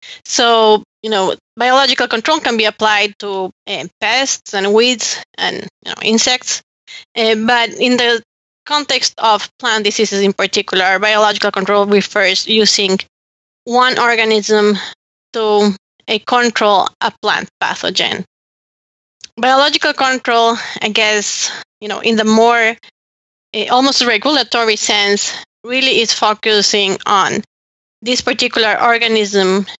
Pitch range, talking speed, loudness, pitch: 210-245 Hz, 120 wpm, -13 LUFS, 220 Hz